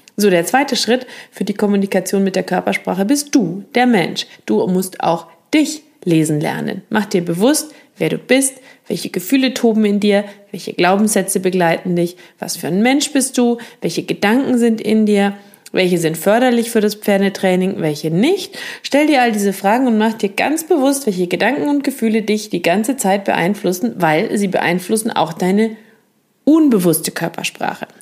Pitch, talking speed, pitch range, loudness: 210 Hz, 170 wpm, 185-245 Hz, -16 LUFS